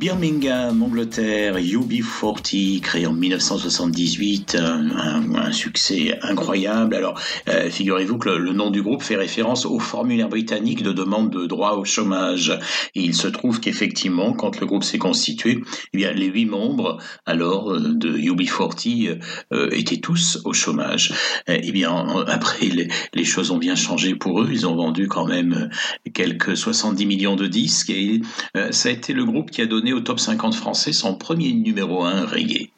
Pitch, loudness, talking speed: 170 Hz, -20 LUFS, 160 wpm